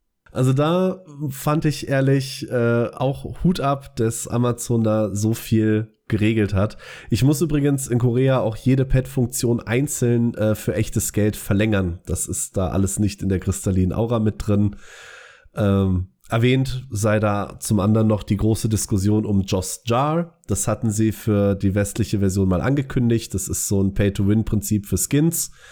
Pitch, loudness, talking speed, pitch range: 110 Hz, -21 LUFS, 165 wpm, 100-130 Hz